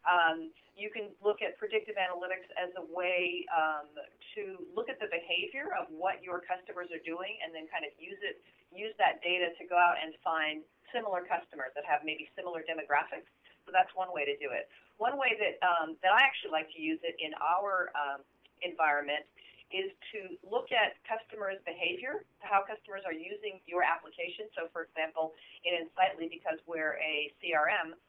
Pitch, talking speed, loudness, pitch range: 180 Hz, 185 wpm, -33 LUFS, 160-210 Hz